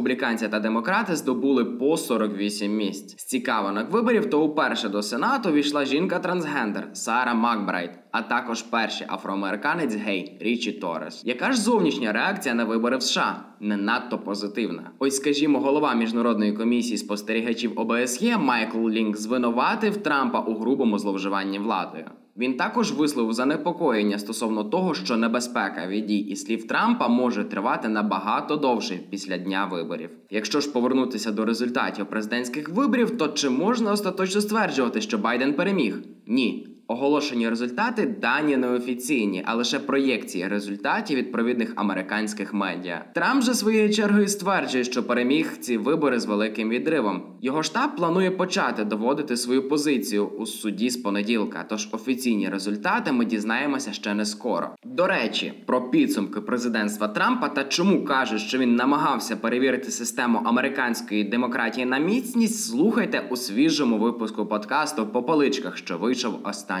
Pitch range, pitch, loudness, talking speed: 105-150 Hz, 120 Hz, -24 LUFS, 140 wpm